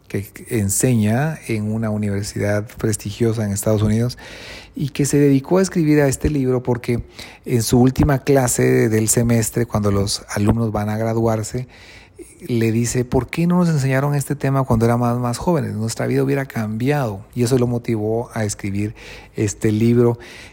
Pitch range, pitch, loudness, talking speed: 110-130 Hz, 120 Hz, -19 LUFS, 165 wpm